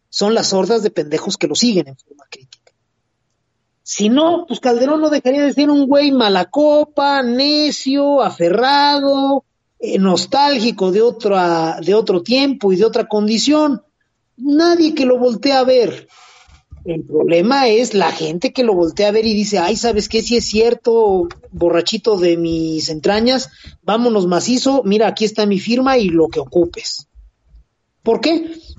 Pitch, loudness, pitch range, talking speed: 225 Hz, -15 LUFS, 180-275 Hz, 160 wpm